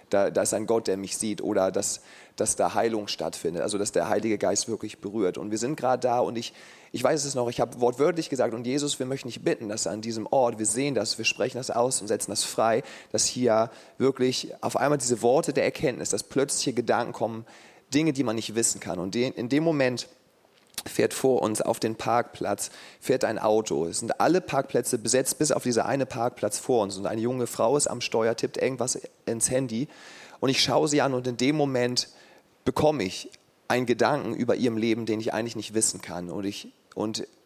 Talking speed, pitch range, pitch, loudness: 220 wpm, 110-130 Hz, 120 Hz, -26 LUFS